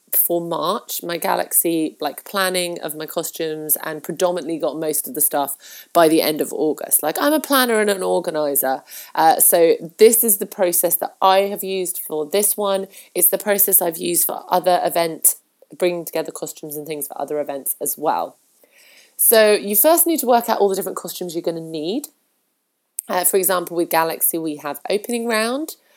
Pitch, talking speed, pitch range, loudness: 180 Hz, 190 wpm, 160-205 Hz, -18 LUFS